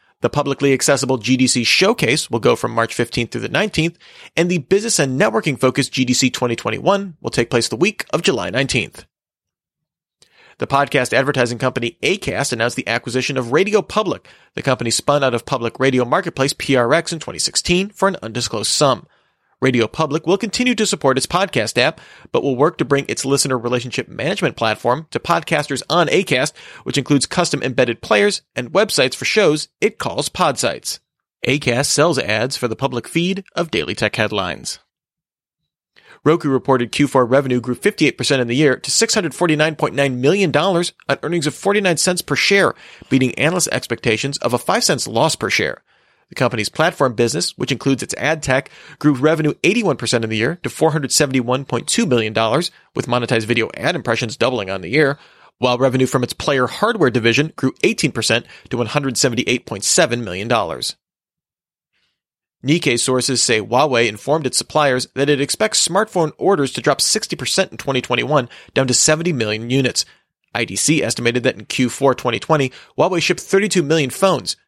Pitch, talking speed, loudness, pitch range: 135 Hz, 165 wpm, -17 LUFS, 120-160 Hz